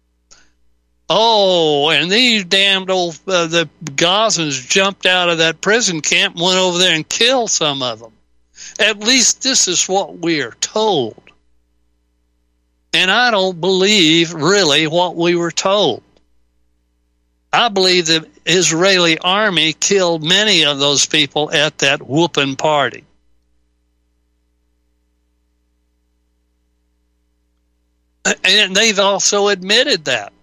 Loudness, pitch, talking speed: -13 LUFS, 160 Hz, 115 wpm